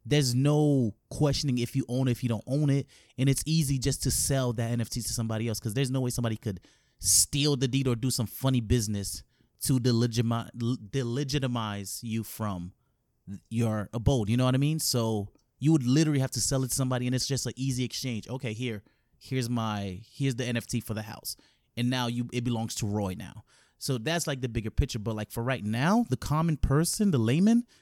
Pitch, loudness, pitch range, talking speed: 125 Hz, -28 LUFS, 115-135 Hz, 210 wpm